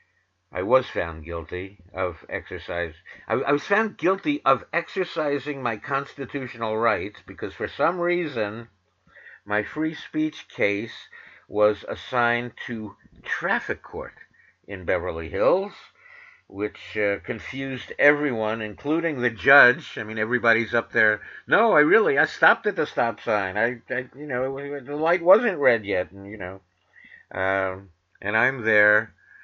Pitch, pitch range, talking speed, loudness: 120 Hz, 105-150 Hz, 140 wpm, -23 LUFS